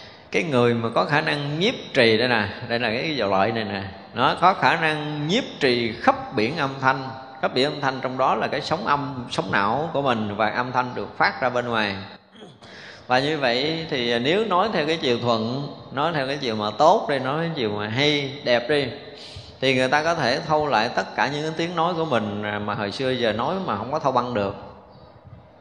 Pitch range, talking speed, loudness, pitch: 115-150 Hz, 230 wpm, -22 LUFS, 130 Hz